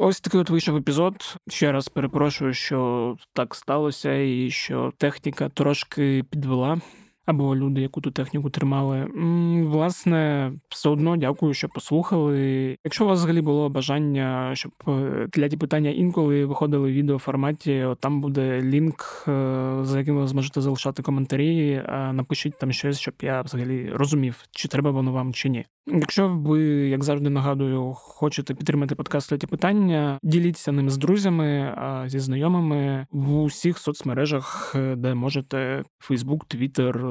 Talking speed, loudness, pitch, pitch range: 145 wpm, -24 LUFS, 140 Hz, 135-155 Hz